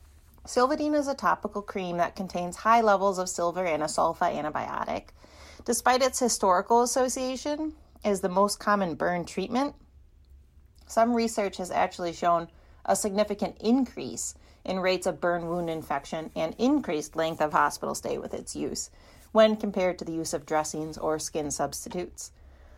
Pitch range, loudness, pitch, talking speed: 160-225 Hz, -28 LUFS, 185 Hz, 155 wpm